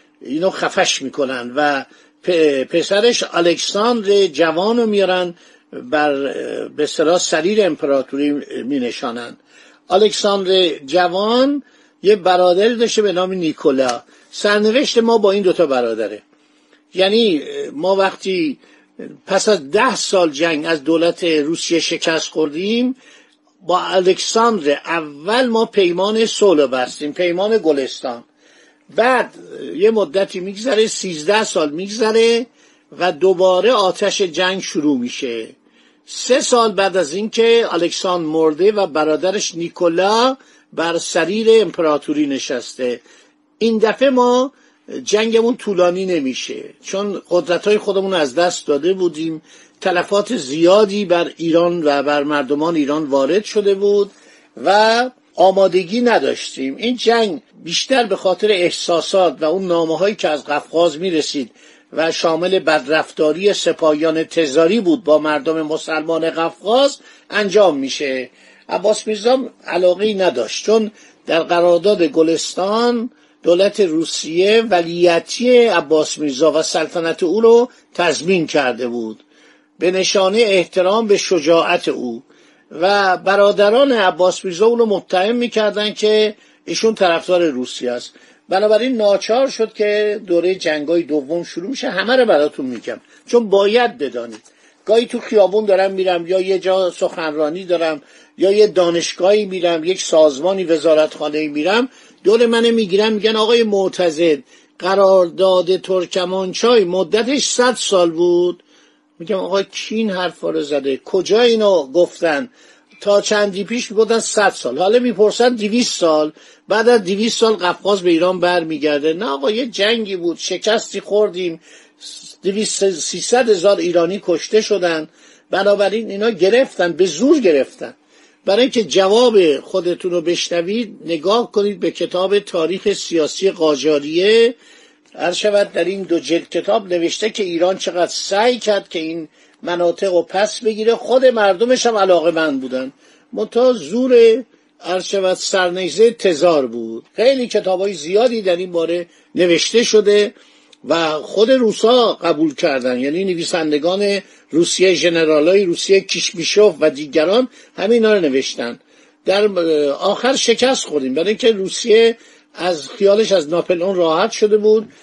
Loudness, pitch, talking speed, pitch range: -16 LUFS, 190 Hz, 125 wpm, 170-220 Hz